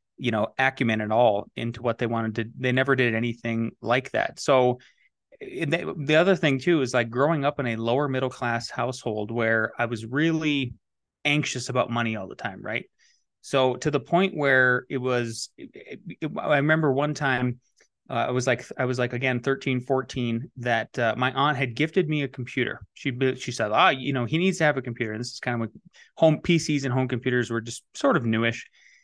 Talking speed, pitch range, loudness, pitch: 215 wpm, 120-140 Hz, -25 LUFS, 125 Hz